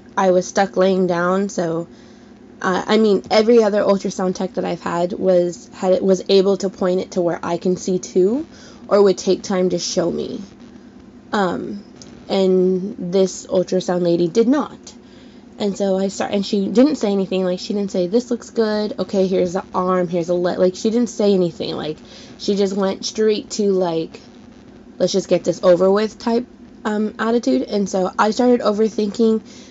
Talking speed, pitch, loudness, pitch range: 185 wpm, 195 Hz, -18 LUFS, 185-215 Hz